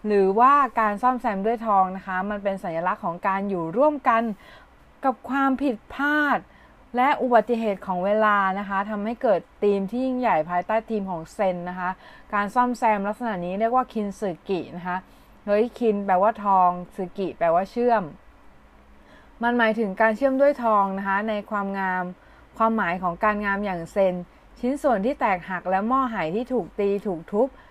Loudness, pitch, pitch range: -23 LUFS, 205 Hz, 190-240 Hz